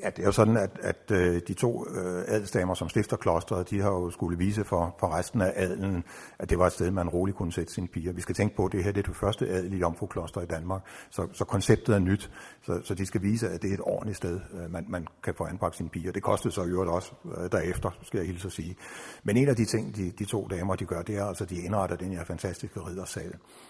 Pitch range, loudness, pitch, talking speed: 90-105 Hz, -30 LUFS, 95 Hz, 265 wpm